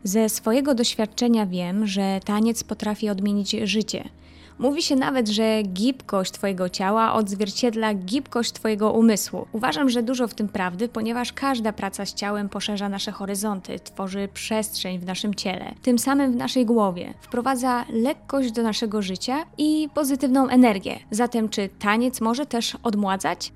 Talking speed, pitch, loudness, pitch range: 150 wpm, 220 Hz, -23 LUFS, 205-245 Hz